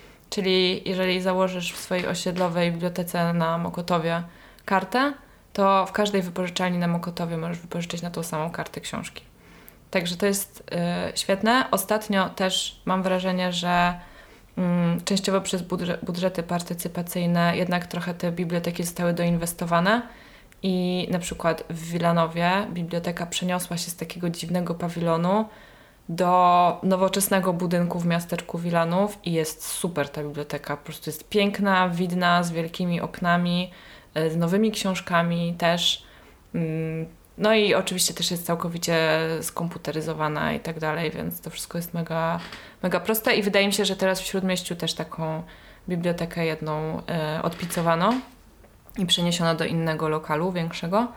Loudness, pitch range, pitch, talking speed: -25 LUFS, 170-185 Hz, 175 Hz, 135 wpm